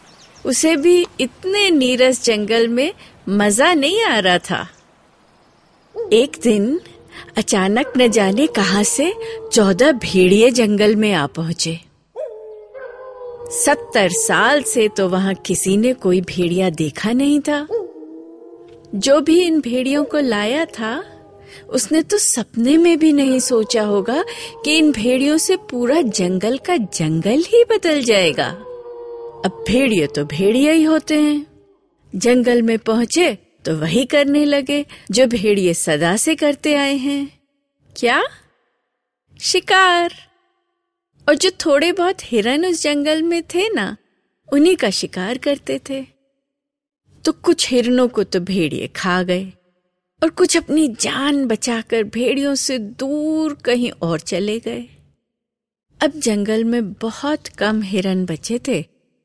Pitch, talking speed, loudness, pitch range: 260 Hz, 130 wpm, -16 LUFS, 210-315 Hz